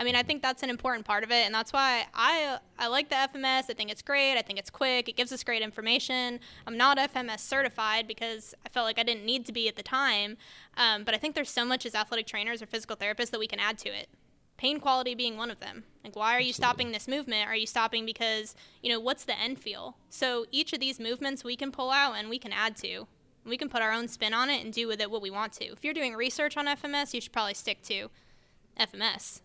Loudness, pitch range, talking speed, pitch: -29 LUFS, 225-265 Hz, 270 wpm, 240 Hz